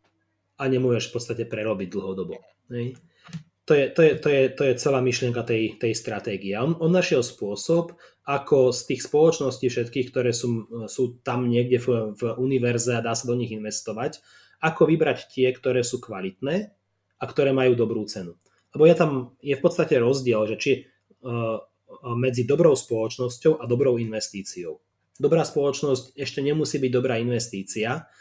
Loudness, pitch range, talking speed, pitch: -24 LUFS, 115-140 Hz, 160 wpm, 125 Hz